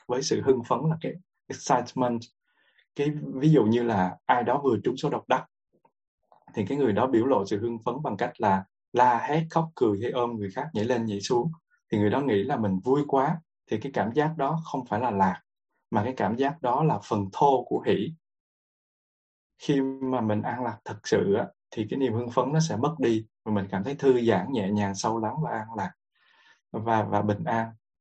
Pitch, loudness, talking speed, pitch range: 120 Hz, -27 LUFS, 220 wpm, 105-140 Hz